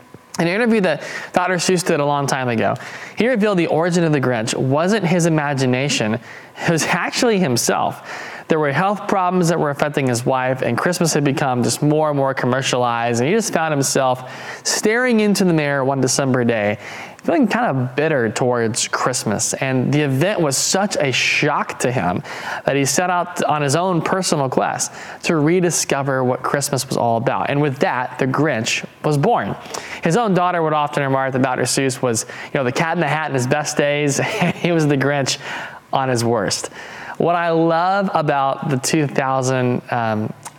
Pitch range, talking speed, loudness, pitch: 130-170 Hz, 190 wpm, -18 LUFS, 145 Hz